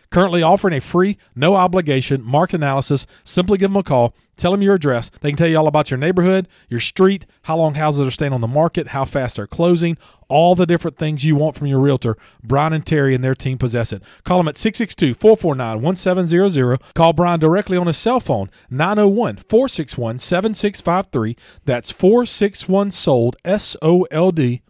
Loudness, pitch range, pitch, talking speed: -17 LUFS, 135-185 Hz, 160 Hz, 180 wpm